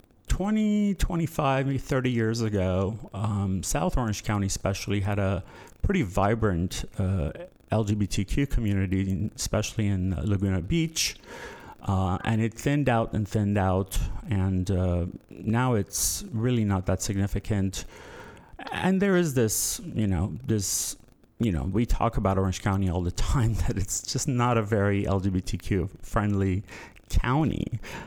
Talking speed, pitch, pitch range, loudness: 135 wpm, 105 Hz, 95-115 Hz, -27 LUFS